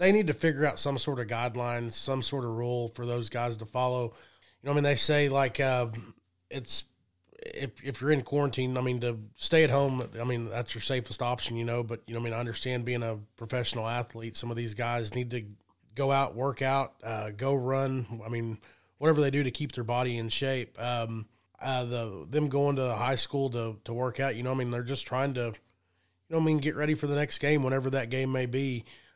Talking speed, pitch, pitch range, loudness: 245 wpm, 125 Hz, 115-135 Hz, -30 LUFS